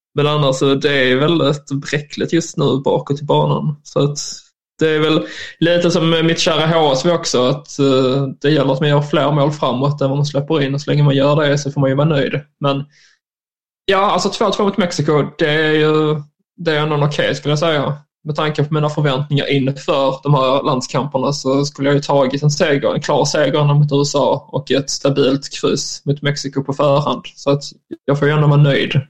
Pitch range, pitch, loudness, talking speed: 140-155 Hz, 145 Hz, -16 LUFS, 210 wpm